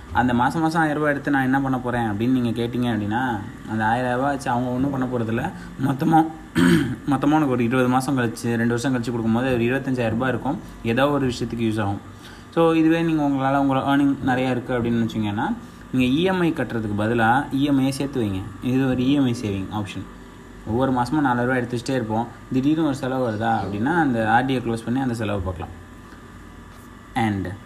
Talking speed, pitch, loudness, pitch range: 175 wpm, 125 Hz, -22 LUFS, 115-135 Hz